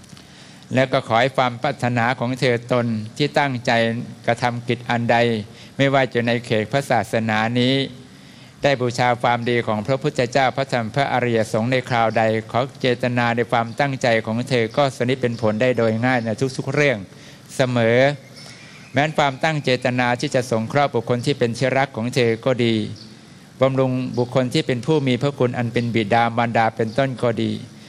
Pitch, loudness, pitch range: 125 Hz, -20 LUFS, 115-135 Hz